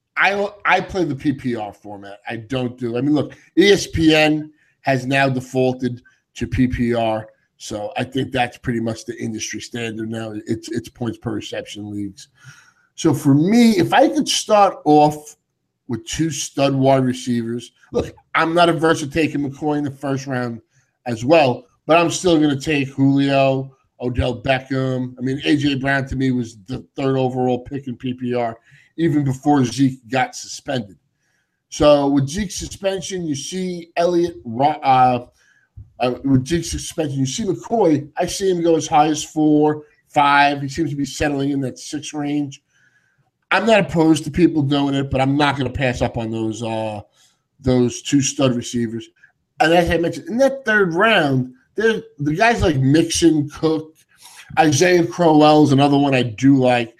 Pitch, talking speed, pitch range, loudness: 140 Hz, 170 wpm, 125-155 Hz, -18 LUFS